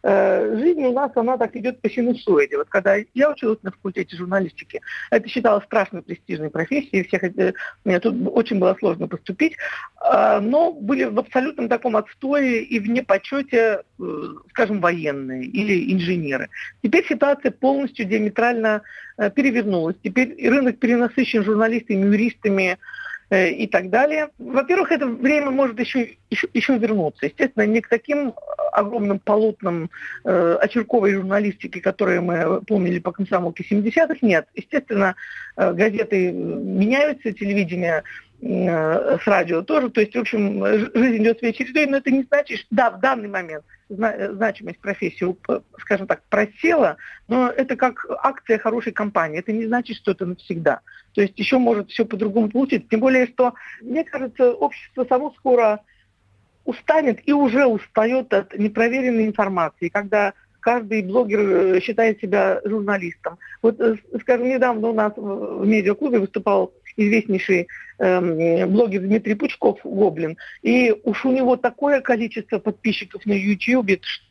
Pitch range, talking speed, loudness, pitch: 195-255 Hz, 135 wpm, -20 LUFS, 220 Hz